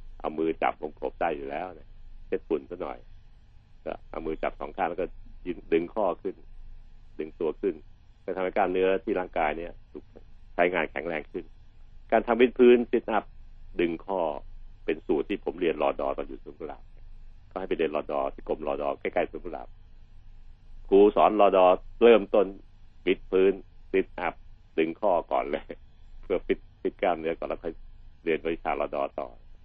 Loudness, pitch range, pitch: -27 LUFS, 80-100 Hz, 90 Hz